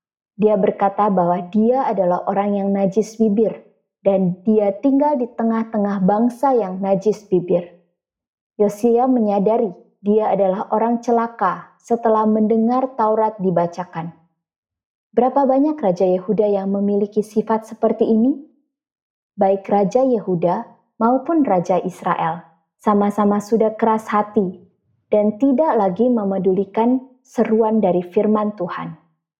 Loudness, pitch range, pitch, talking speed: -18 LUFS, 190-230 Hz, 210 Hz, 110 wpm